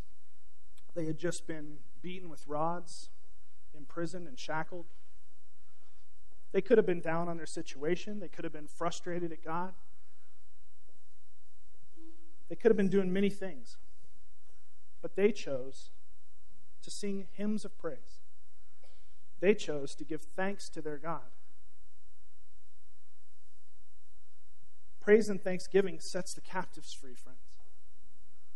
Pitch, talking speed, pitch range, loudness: 170 Hz, 120 wpm, 155-190 Hz, -35 LUFS